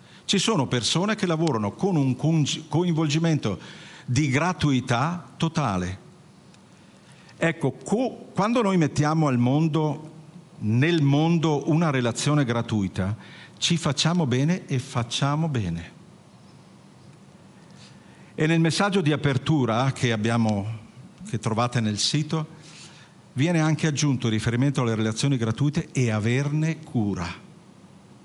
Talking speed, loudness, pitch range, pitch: 110 wpm, -24 LUFS, 120-165 Hz, 150 Hz